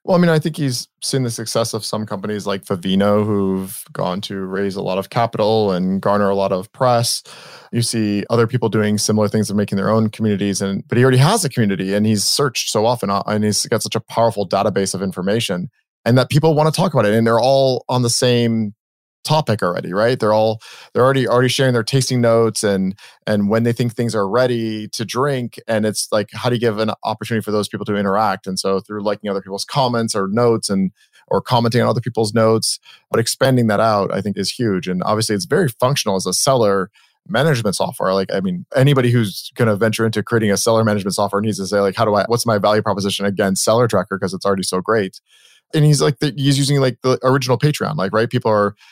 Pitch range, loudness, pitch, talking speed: 100-125 Hz, -17 LUFS, 110 Hz, 235 wpm